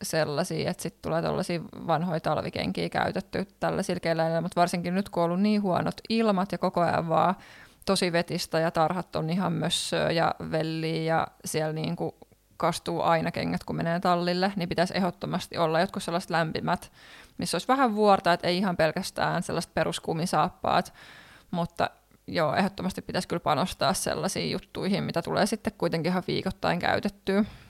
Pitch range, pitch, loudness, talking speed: 165-190 Hz, 175 Hz, -28 LUFS, 165 wpm